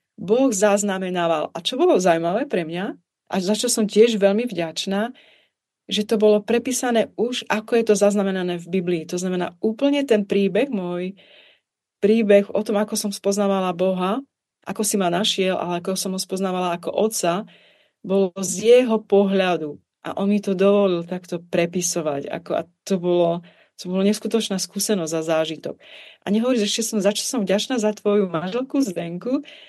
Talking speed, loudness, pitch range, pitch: 170 wpm, -21 LUFS, 180-220 Hz, 200 Hz